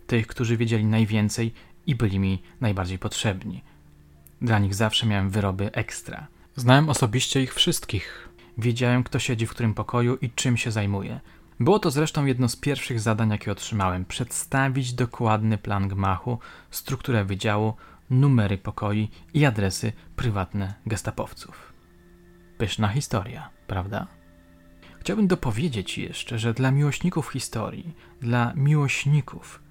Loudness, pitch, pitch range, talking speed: -25 LUFS, 115 Hz, 100-130 Hz, 125 wpm